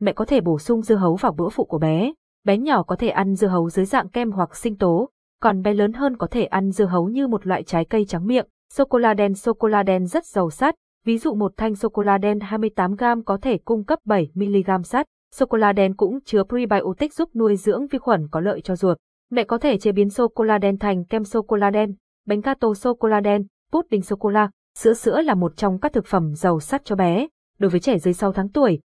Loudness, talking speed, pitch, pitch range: -21 LUFS, 265 wpm, 210 Hz, 195-235 Hz